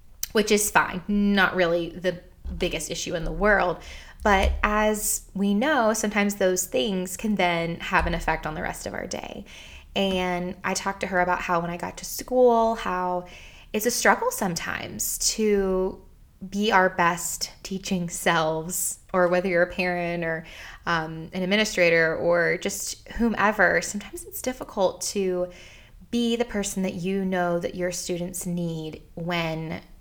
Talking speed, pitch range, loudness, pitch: 160 wpm, 170-205 Hz, -24 LUFS, 180 Hz